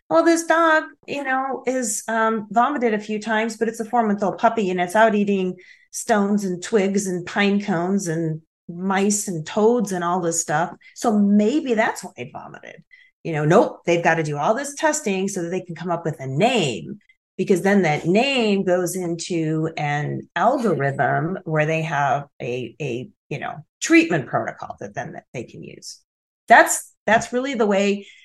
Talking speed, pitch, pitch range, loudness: 185 wpm, 200 Hz, 170-230 Hz, -20 LUFS